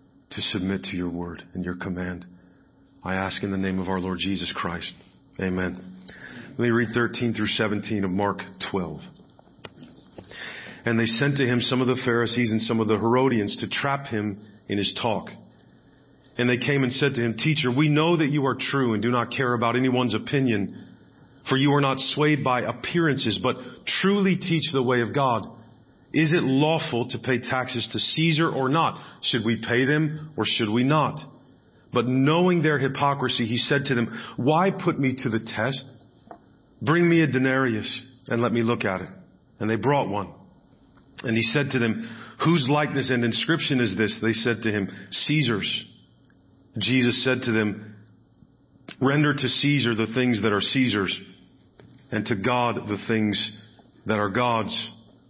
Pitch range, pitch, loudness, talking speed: 110-135 Hz, 120 Hz, -24 LUFS, 180 wpm